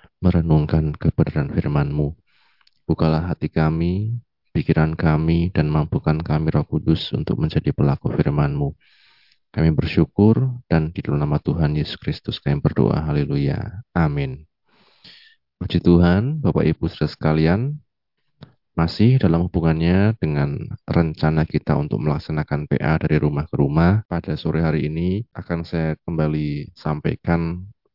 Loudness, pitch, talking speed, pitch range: -20 LUFS, 80 Hz, 120 wpm, 75-85 Hz